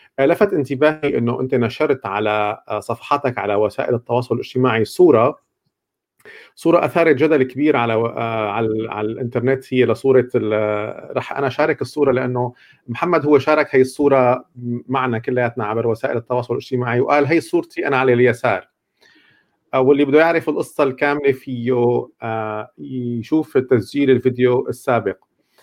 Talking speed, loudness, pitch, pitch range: 135 wpm, -18 LUFS, 125 Hz, 115-145 Hz